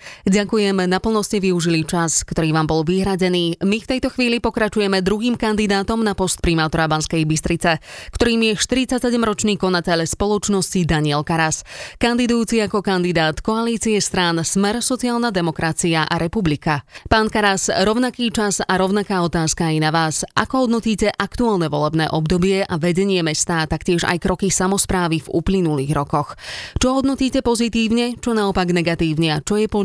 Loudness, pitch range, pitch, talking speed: -18 LUFS, 165-220 Hz, 190 Hz, 145 wpm